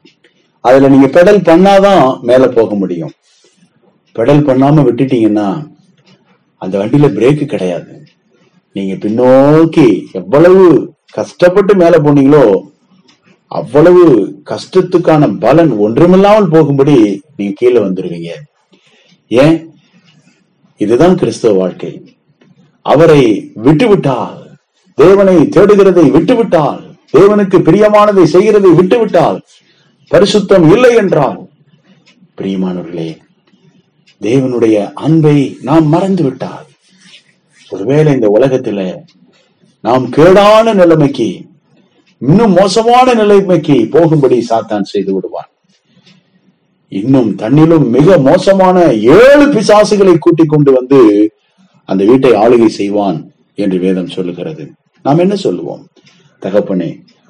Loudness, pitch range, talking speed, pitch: -8 LUFS, 130-190 Hz, 85 wpm, 165 Hz